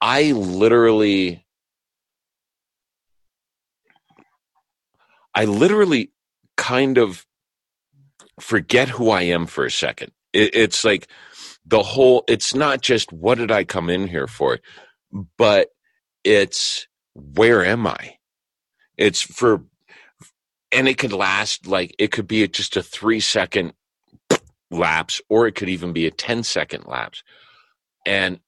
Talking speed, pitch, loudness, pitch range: 120 wpm, 110 Hz, -19 LUFS, 95-130 Hz